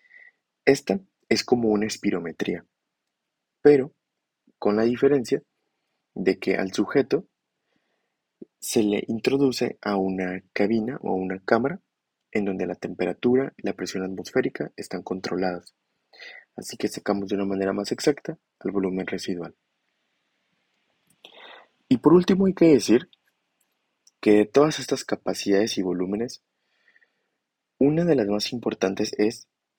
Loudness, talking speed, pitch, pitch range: -24 LUFS, 125 wpm, 105 Hz, 95-135 Hz